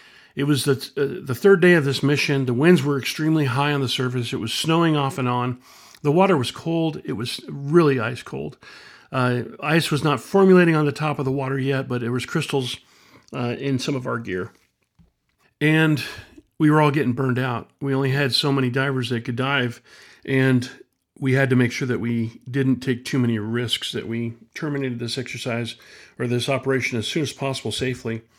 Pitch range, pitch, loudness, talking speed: 125-145 Hz, 135 Hz, -21 LUFS, 205 wpm